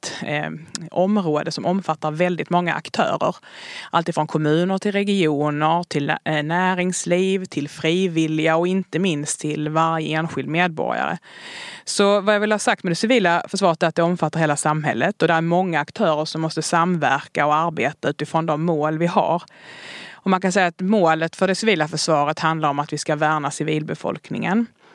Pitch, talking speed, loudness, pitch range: 165 Hz, 165 wpm, -20 LUFS, 155-185 Hz